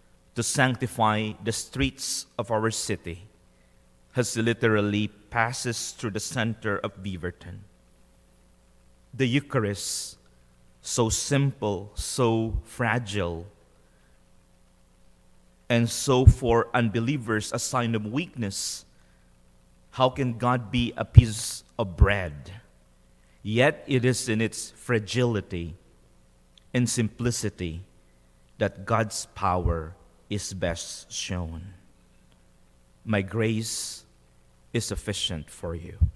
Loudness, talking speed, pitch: -26 LUFS, 95 wpm, 100 Hz